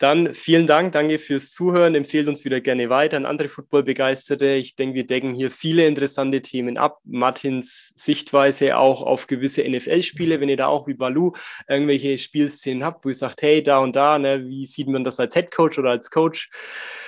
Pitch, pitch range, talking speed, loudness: 140 Hz, 130-150 Hz, 195 wpm, -20 LUFS